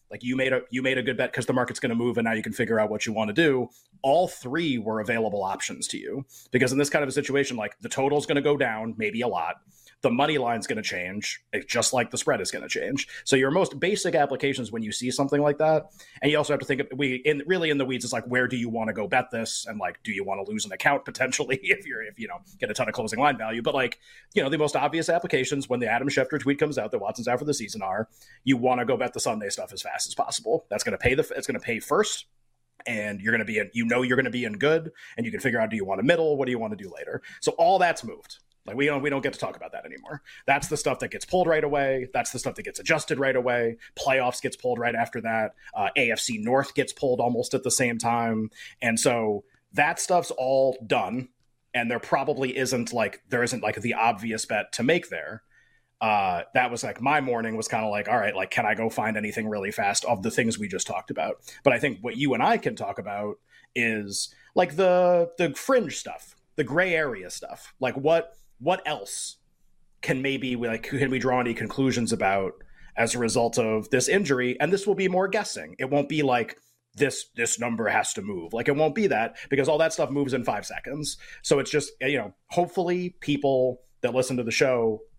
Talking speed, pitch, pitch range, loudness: 260 wpm, 130 Hz, 115-145 Hz, -26 LUFS